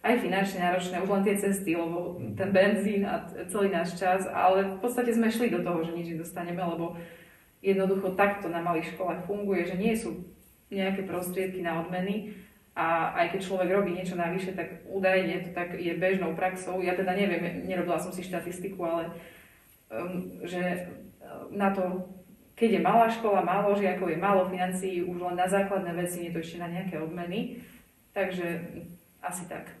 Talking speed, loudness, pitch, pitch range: 175 wpm, -29 LUFS, 180 Hz, 175-195 Hz